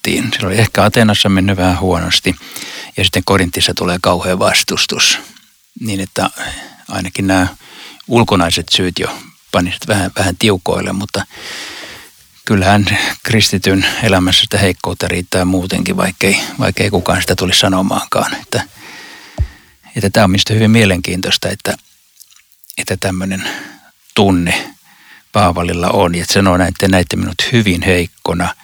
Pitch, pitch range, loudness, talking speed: 95 Hz, 90-100 Hz, -13 LUFS, 125 wpm